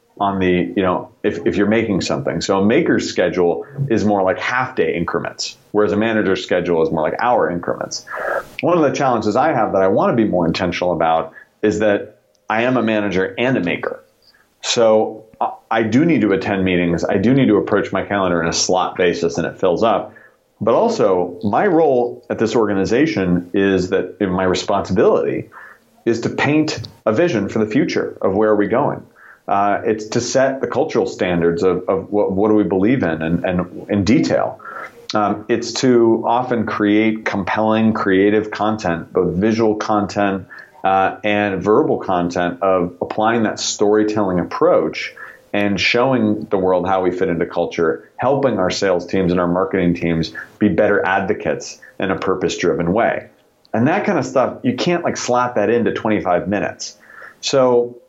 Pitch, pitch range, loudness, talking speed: 100 Hz, 90-110 Hz, -17 LUFS, 180 wpm